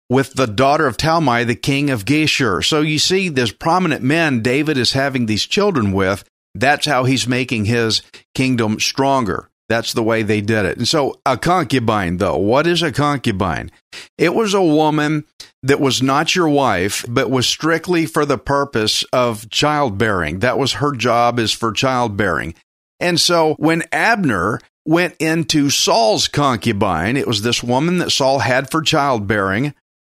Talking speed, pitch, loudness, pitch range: 170 wpm, 130 Hz, -16 LUFS, 115-150 Hz